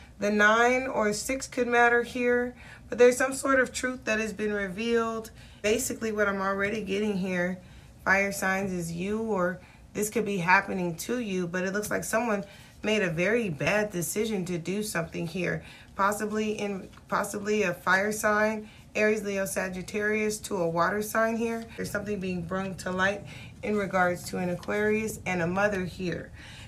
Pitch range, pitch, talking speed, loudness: 185-215 Hz, 205 Hz, 175 wpm, -28 LUFS